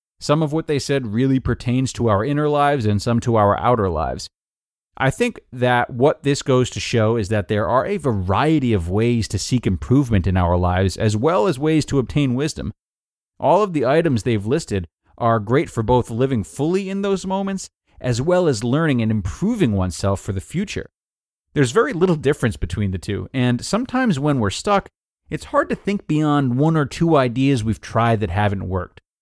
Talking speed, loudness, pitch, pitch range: 200 wpm, -19 LUFS, 125 Hz, 105-150 Hz